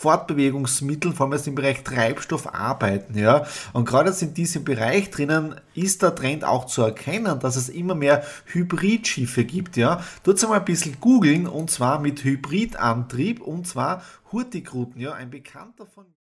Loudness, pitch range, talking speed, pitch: -22 LUFS, 130-180 Hz, 165 wpm, 145 Hz